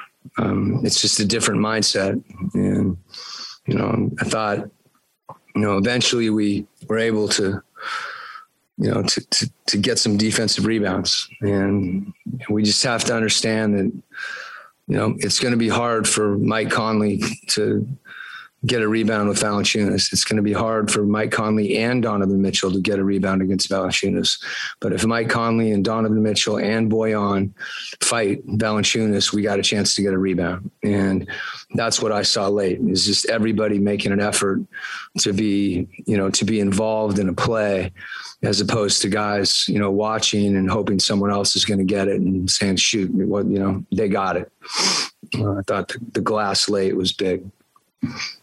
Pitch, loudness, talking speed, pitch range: 105 Hz, -20 LUFS, 175 wpm, 100-110 Hz